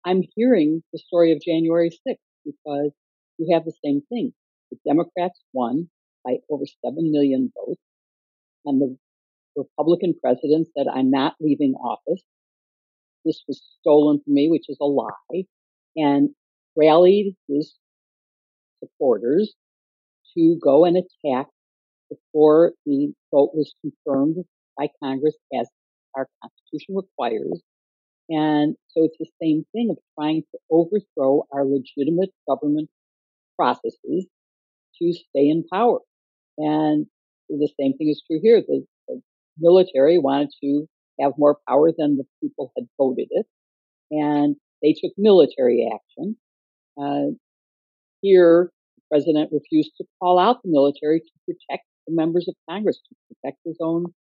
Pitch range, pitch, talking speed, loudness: 140-180 Hz, 155 Hz, 135 wpm, -21 LUFS